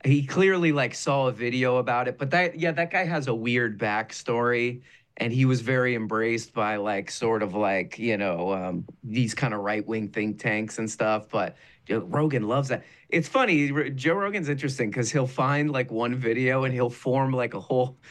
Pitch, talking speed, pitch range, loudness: 125 Hz, 200 wpm, 115-145 Hz, -26 LUFS